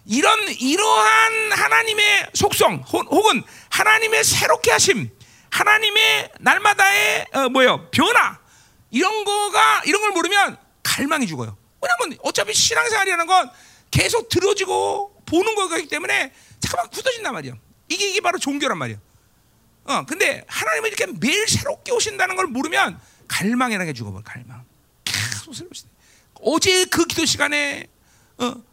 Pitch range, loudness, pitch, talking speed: 260-420 Hz, -18 LUFS, 370 Hz, 315 characters per minute